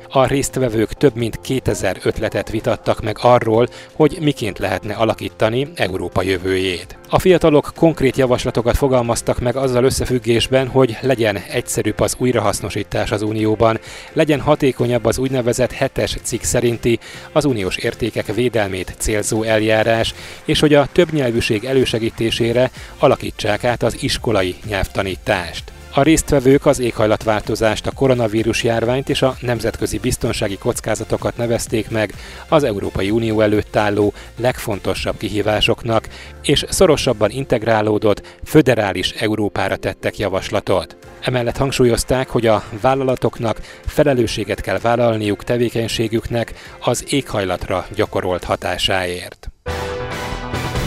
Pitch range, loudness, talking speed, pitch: 105-125 Hz, -18 LUFS, 110 wpm, 115 Hz